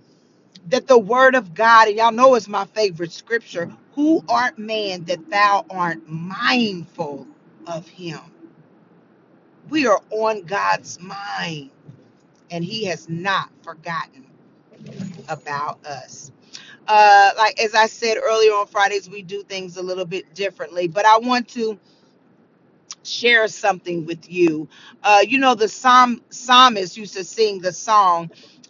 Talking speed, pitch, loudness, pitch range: 140 wpm, 200 Hz, -17 LUFS, 175-225 Hz